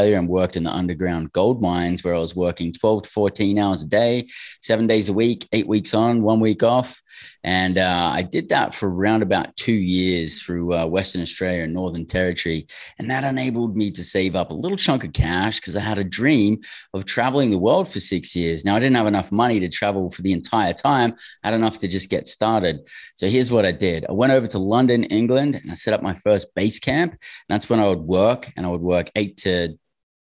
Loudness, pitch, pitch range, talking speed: -20 LUFS, 100 Hz, 90-115 Hz, 235 wpm